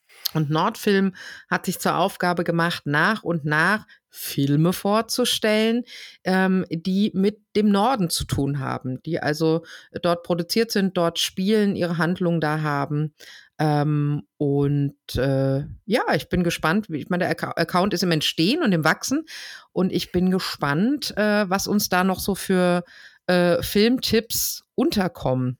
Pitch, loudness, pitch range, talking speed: 175 Hz, -22 LUFS, 155-200 Hz, 150 wpm